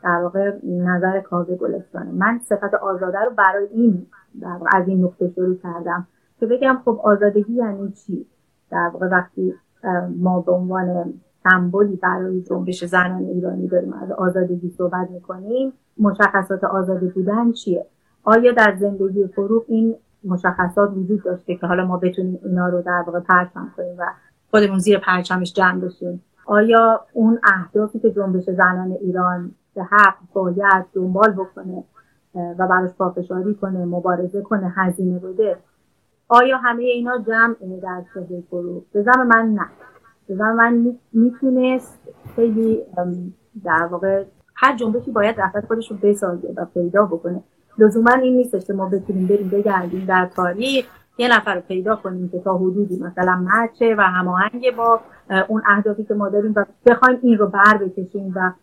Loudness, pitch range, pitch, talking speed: -18 LUFS, 180-220 Hz, 195 Hz, 150 wpm